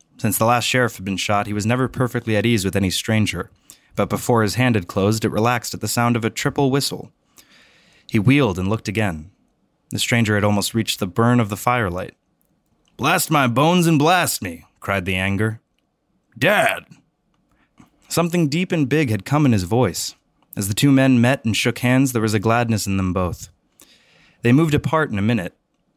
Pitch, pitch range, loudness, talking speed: 115 Hz, 105-125 Hz, -19 LUFS, 200 wpm